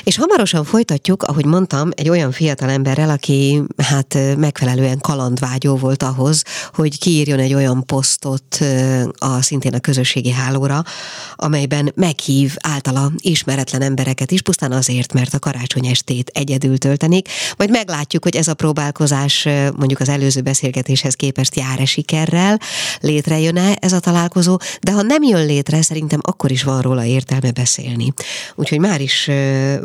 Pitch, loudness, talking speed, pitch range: 140 Hz, -16 LUFS, 145 wpm, 135-160 Hz